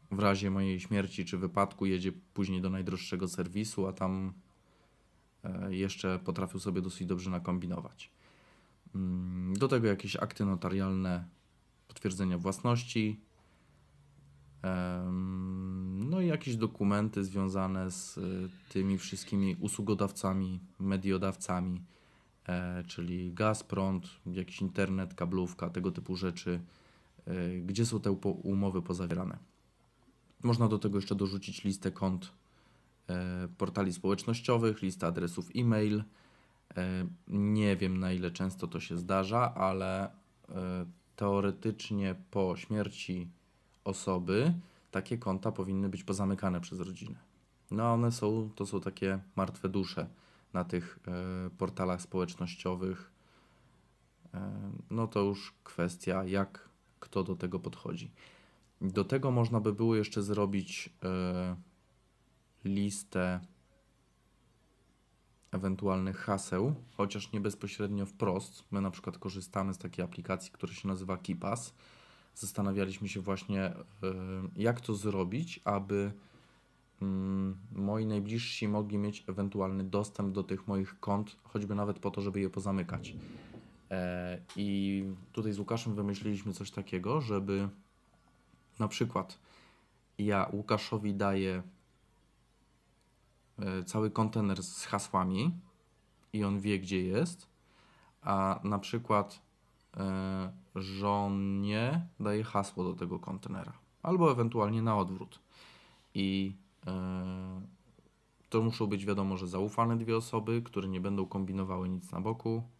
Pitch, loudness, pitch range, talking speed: 95 Hz, -35 LUFS, 95-105 Hz, 115 wpm